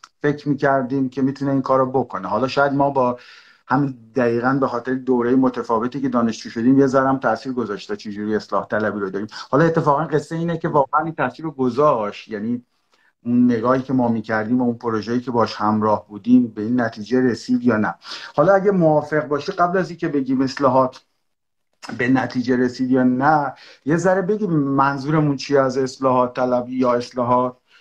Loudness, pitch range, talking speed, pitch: -20 LUFS, 125-145 Hz, 180 wpm, 130 Hz